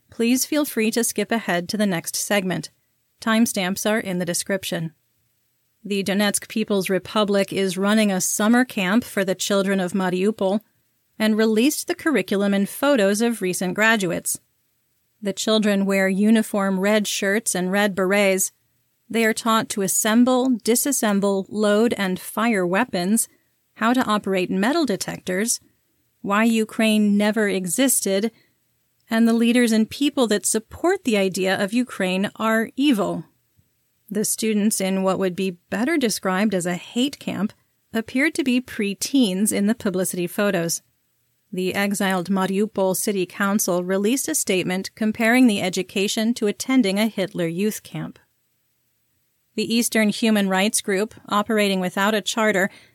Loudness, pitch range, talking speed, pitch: -21 LUFS, 190-225 Hz, 145 wpm, 205 Hz